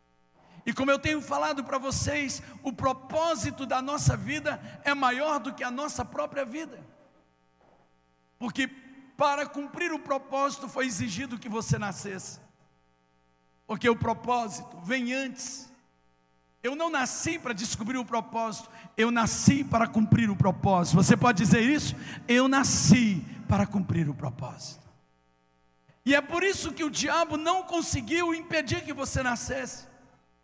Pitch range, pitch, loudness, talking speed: 165-275 Hz, 245 Hz, -27 LUFS, 140 wpm